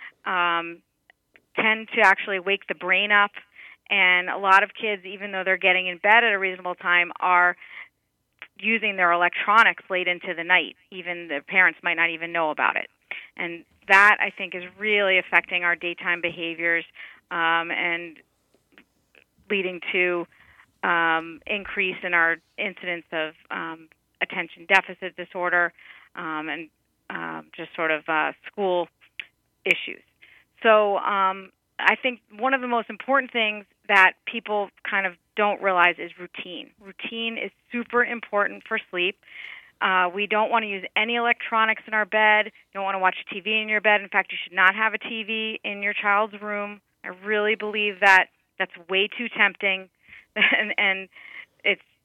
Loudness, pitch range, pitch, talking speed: -22 LUFS, 175-210 Hz, 190 Hz, 160 wpm